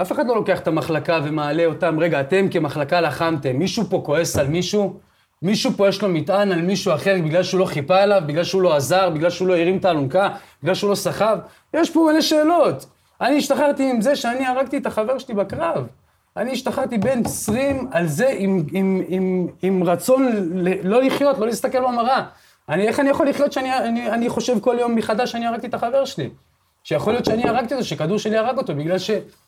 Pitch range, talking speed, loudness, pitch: 175-250 Hz, 210 wpm, -20 LUFS, 195 Hz